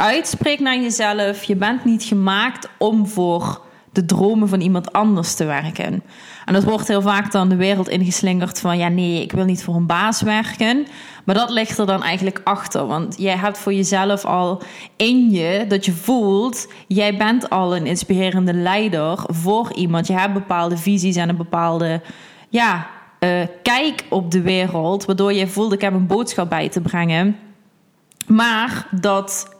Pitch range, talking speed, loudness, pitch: 180-215 Hz, 175 wpm, -18 LUFS, 195 Hz